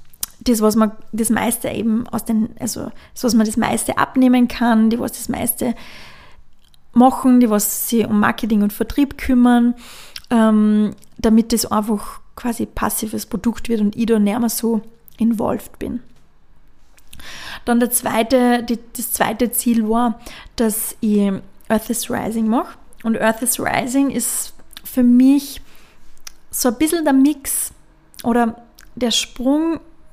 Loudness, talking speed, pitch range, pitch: -18 LUFS, 145 wpm, 220-245 Hz, 230 Hz